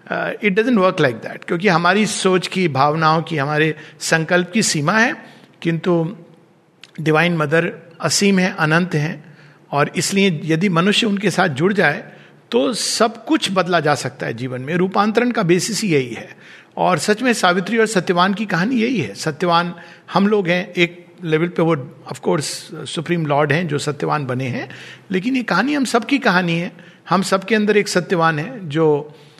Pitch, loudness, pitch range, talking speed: 175 Hz, -18 LUFS, 160-200 Hz, 175 wpm